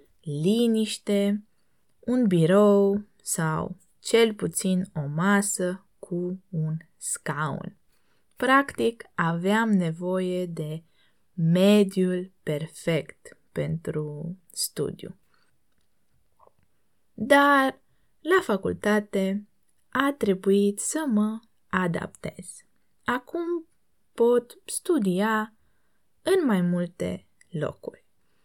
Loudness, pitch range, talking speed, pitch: -25 LUFS, 175-225 Hz, 70 wpm, 200 Hz